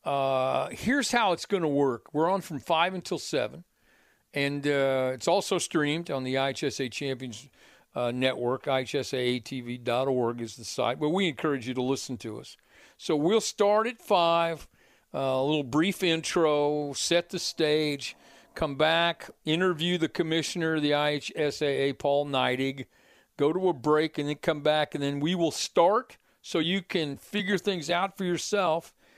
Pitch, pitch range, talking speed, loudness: 150 Hz, 135-170 Hz, 165 wpm, -28 LUFS